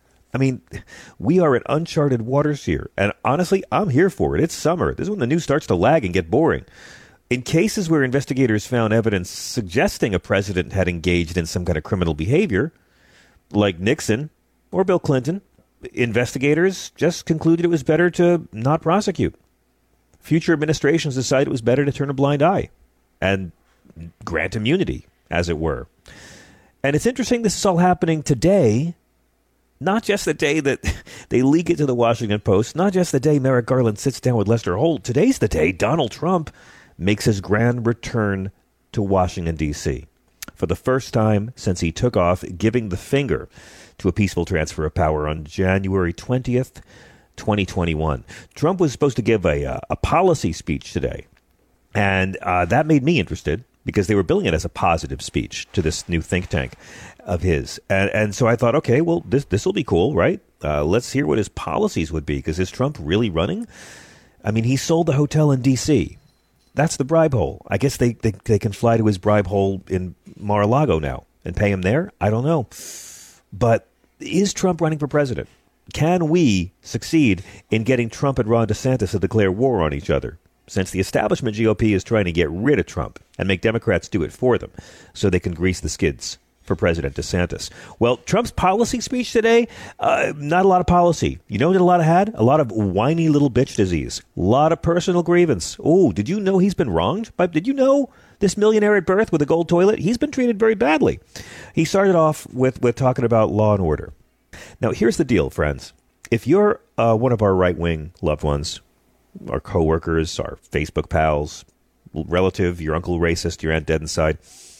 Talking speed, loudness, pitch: 195 wpm, -20 LUFS, 115 Hz